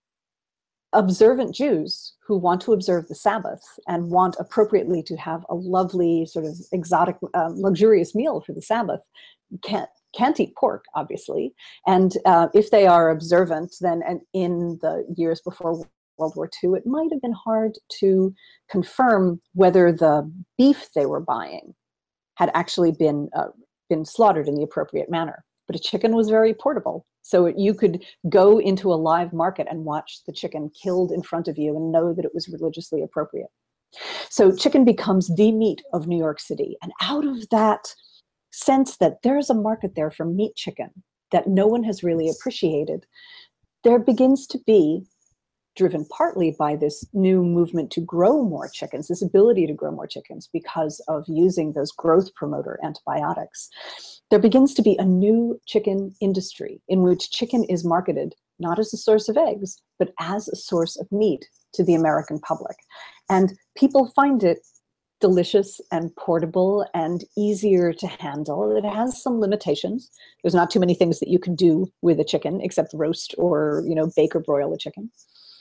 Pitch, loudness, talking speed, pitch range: 180 Hz, -21 LUFS, 175 wpm, 165-215 Hz